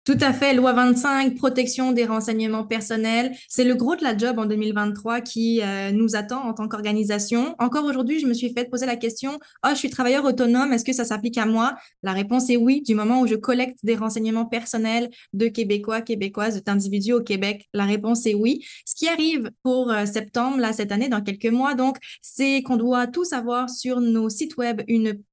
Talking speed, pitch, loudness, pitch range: 210 wpm, 235 Hz, -22 LUFS, 220-255 Hz